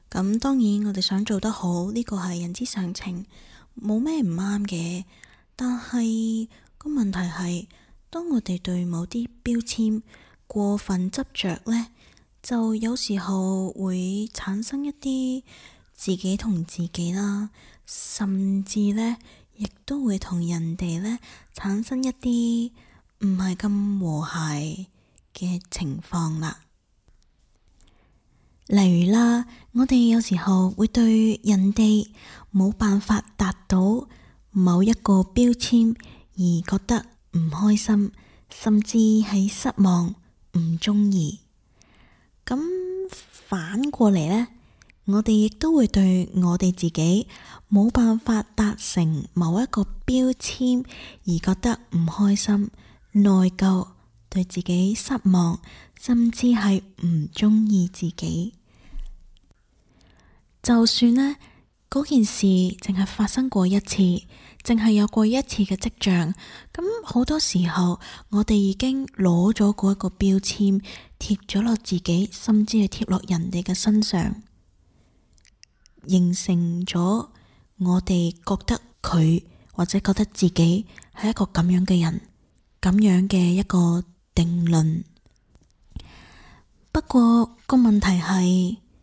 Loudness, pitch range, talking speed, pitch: -22 LUFS, 180-225 Hz, 165 characters per minute, 200 Hz